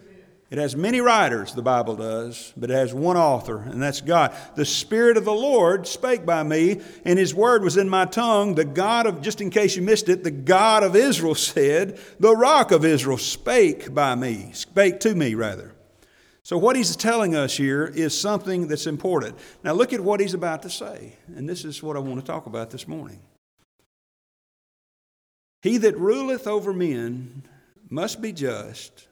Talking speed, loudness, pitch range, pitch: 190 wpm, -21 LUFS, 140-210 Hz, 175 Hz